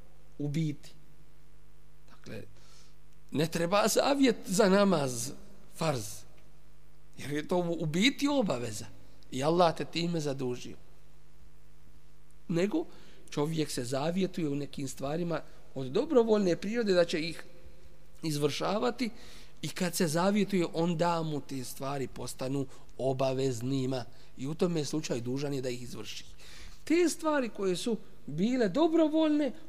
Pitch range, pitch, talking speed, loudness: 135-190 Hz, 155 Hz, 120 wpm, -31 LUFS